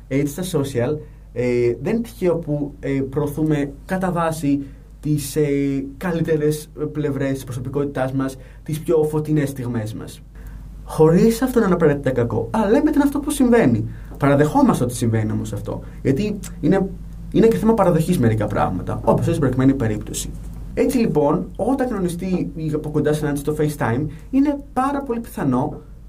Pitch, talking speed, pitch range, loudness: 150 Hz, 155 wpm, 135-175 Hz, -20 LUFS